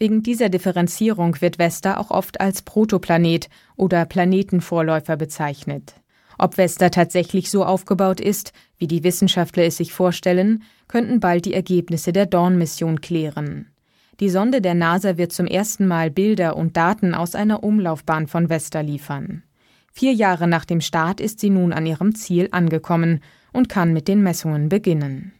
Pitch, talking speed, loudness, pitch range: 180 Hz, 155 wpm, -19 LUFS, 165-195 Hz